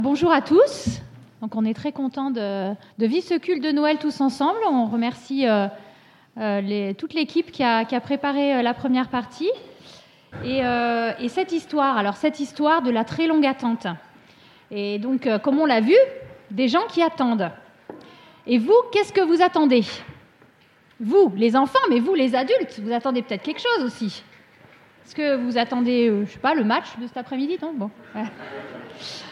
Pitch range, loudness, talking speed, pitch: 230-310 Hz, -22 LUFS, 180 wpm, 260 Hz